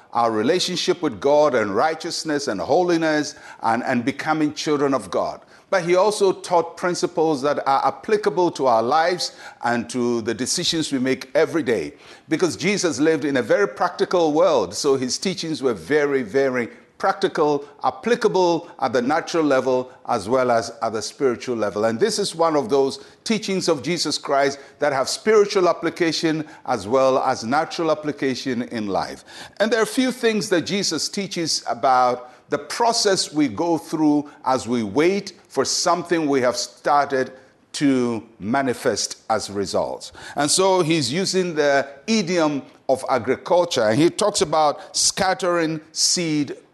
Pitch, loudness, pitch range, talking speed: 155 Hz, -21 LUFS, 130-175 Hz, 155 wpm